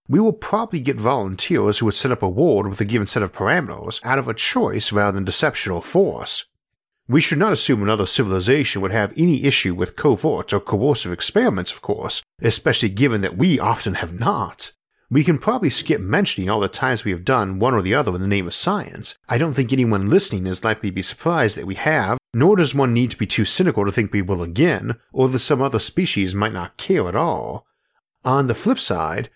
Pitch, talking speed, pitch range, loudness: 115 Hz, 225 wpm, 100-140 Hz, -19 LUFS